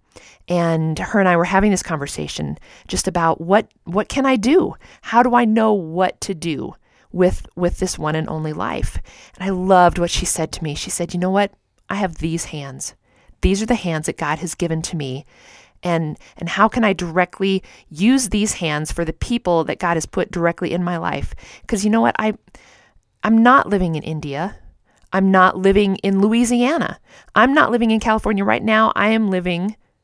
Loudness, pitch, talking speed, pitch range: -18 LUFS, 185 Hz, 200 wpm, 165-210 Hz